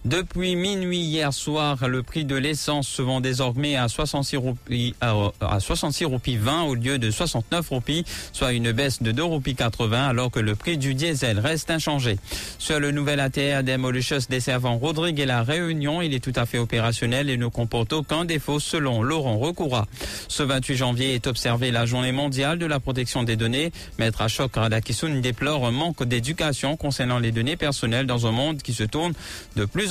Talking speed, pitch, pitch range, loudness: 190 wpm, 135 Hz, 120-150 Hz, -24 LUFS